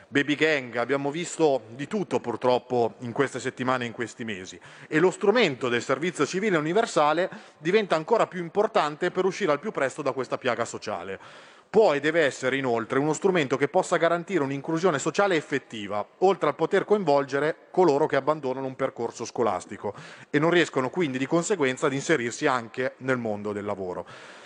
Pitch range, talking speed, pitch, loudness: 130-175 Hz, 170 wpm, 145 Hz, -25 LUFS